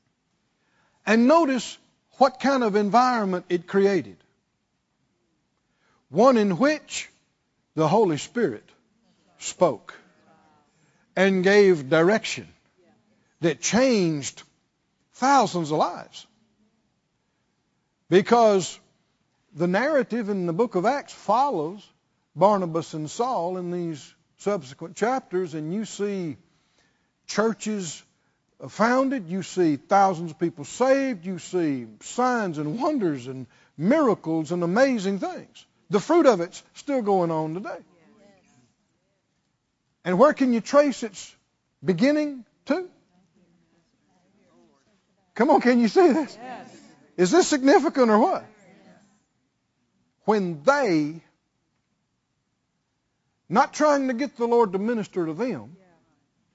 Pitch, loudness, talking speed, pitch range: 195 Hz, -23 LUFS, 105 wpm, 170-245 Hz